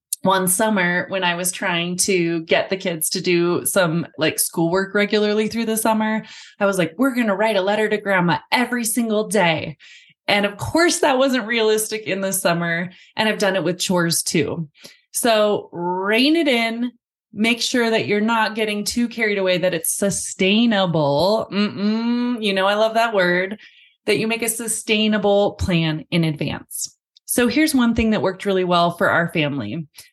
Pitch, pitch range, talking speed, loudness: 205 Hz, 180-225 Hz, 180 wpm, -19 LUFS